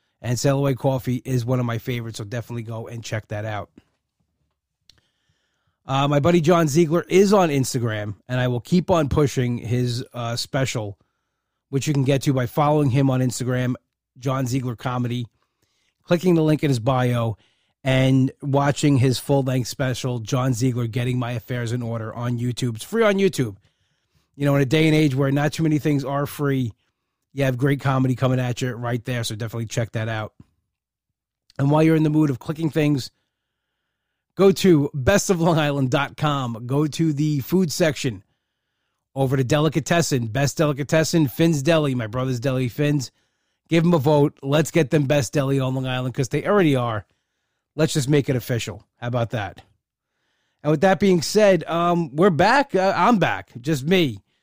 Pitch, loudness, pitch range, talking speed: 135 Hz, -21 LUFS, 120-155 Hz, 180 wpm